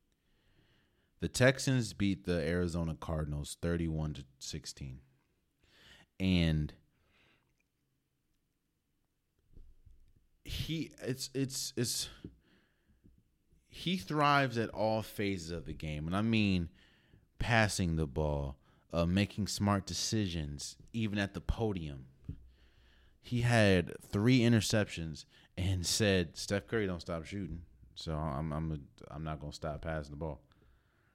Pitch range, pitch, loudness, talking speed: 80-110 Hz, 90 Hz, -34 LUFS, 110 wpm